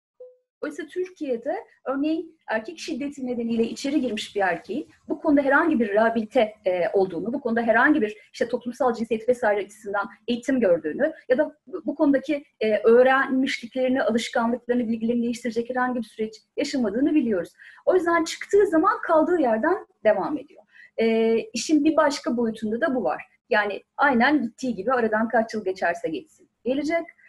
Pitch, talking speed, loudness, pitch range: 255 Hz, 145 wpm, -24 LUFS, 230-310 Hz